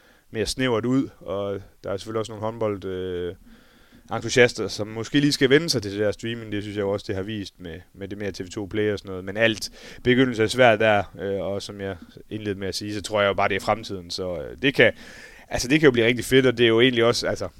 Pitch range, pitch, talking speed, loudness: 100-115 Hz, 105 Hz, 270 wpm, -23 LUFS